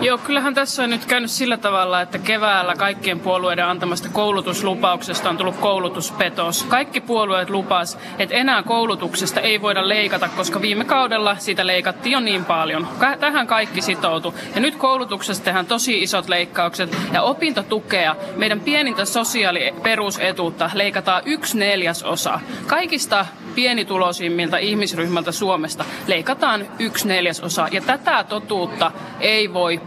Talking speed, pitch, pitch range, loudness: 130 wpm, 195 Hz, 180-230 Hz, -19 LUFS